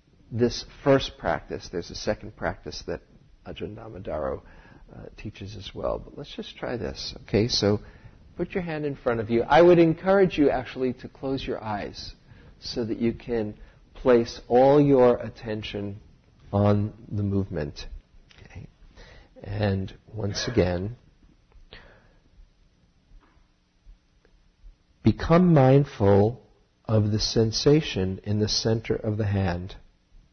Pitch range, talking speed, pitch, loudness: 100-125 Hz, 125 wpm, 110 Hz, -24 LUFS